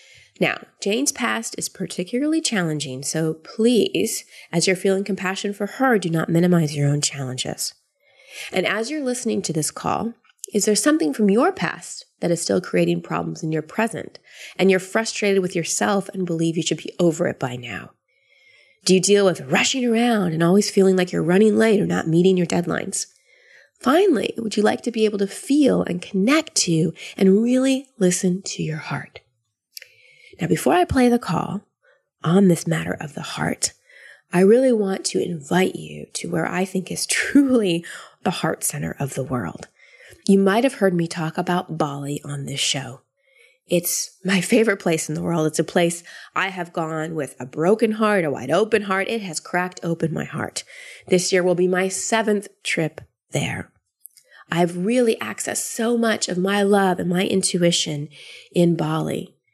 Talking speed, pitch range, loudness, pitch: 180 wpm, 165-220 Hz, -21 LUFS, 185 Hz